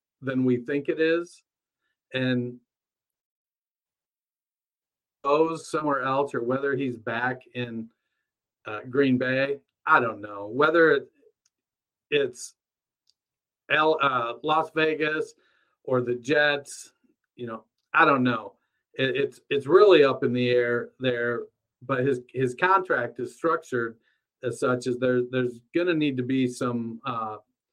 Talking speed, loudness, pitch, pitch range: 135 wpm, -25 LUFS, 130 Hz, 125-155 Hz